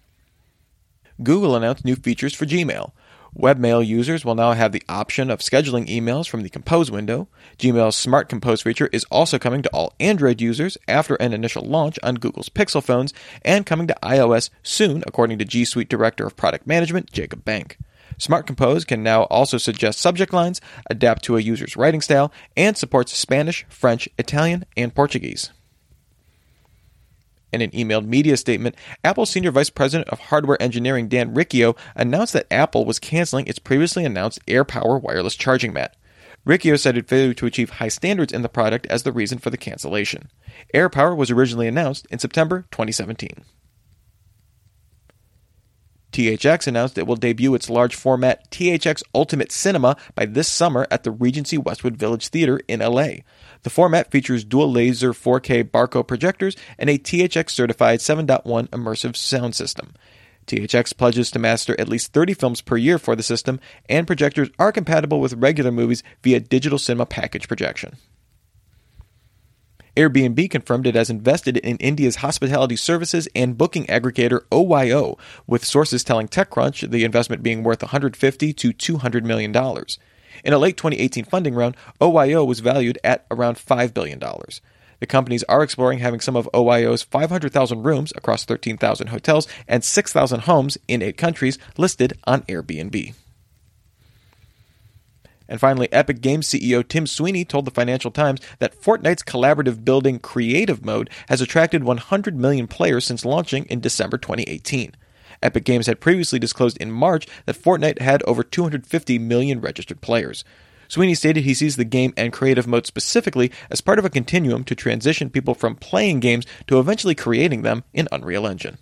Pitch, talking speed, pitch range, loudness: 125 Hz, 160 wpm, 115-150 Hz, -19 LUFS